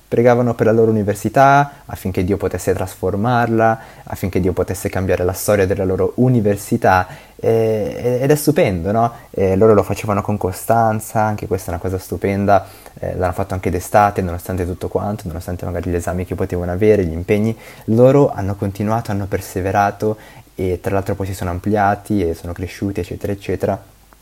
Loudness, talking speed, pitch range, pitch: -17 LUFS, 170 wpm, 95-110 Hz, 100 Hz